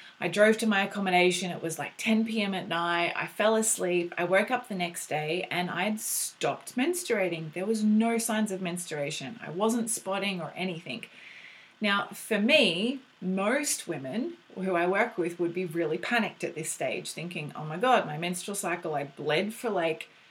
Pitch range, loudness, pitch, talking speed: 170-220 Hz, -29 LUFS, 185 Hz, 185 wpm